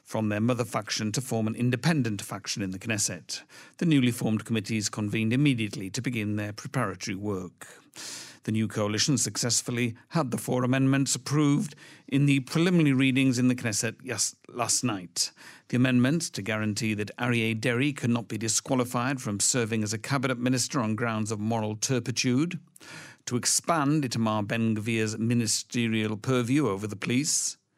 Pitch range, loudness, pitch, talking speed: 110-135 Hz, -27 LUFS, 120 Hz, 160 wpm